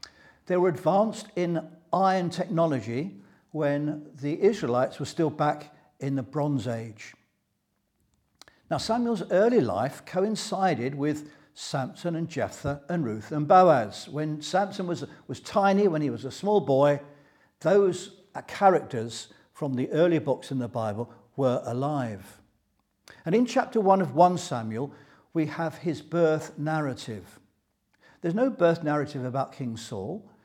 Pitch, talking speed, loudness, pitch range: 150 Hz, 140 wpm, -27 LUFS, 130-180 Hz